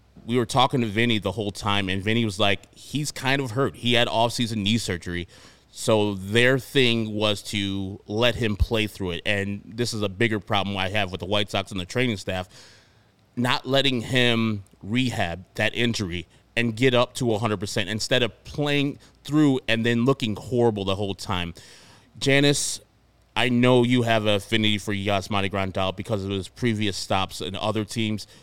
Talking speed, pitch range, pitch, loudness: 185 wpm, 100-120 Hz, 110 Hz, -24 LUFS